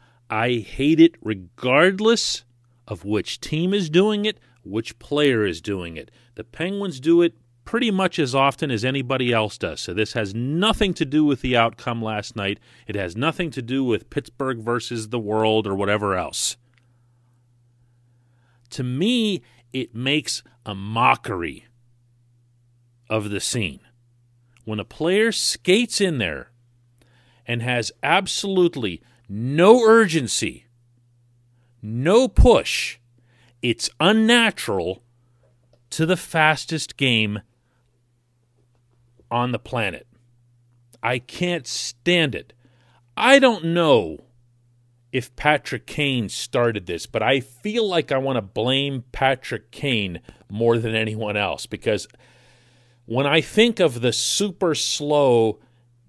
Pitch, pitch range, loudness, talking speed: 120 Hz, 120-145 Hz, -21 LUFS, 125 wpm